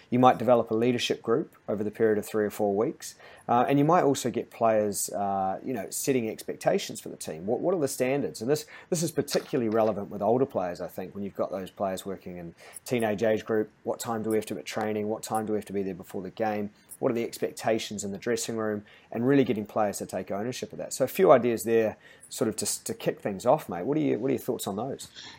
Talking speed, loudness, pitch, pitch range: 265 wpm, -28 LUFS, 110 Hz, 105-120 Hz